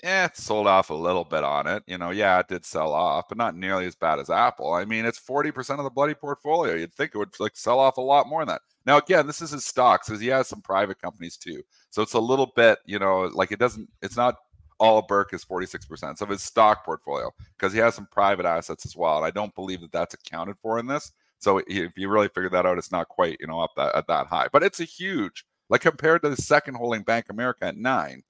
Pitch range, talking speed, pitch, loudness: 95-145 Hz, 270 wpm, 115 Hz, -24 LUFS